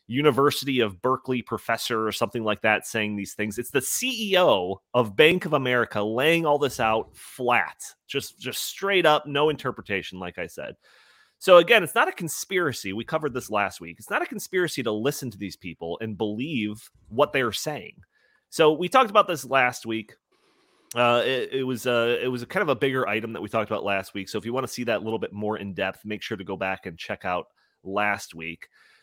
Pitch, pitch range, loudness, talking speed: 115 Hz, 105-145 Hz, -24 LUFS, 220 wpm